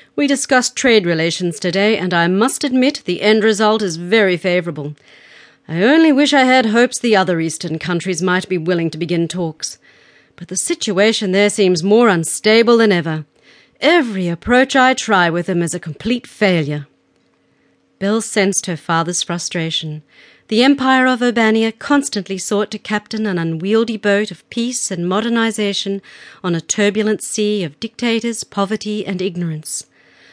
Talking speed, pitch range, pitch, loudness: 155 wpm, 175-225 Hz, 205 Hz, -16 LUFS